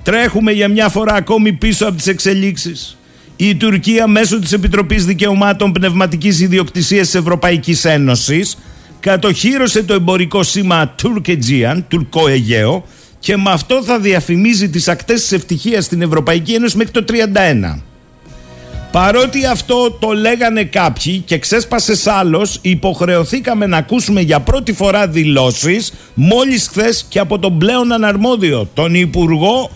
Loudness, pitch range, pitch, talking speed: -12 LUFS, 170-215 Hz, 195 Hz, 135 wpm